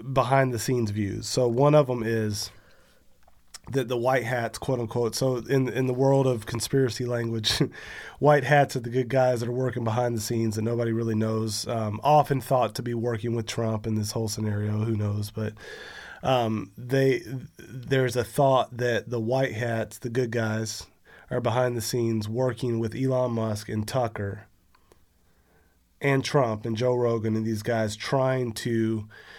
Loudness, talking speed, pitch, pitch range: -26 LUFS, 175 wpm, 120 Hz, 110-130 Hz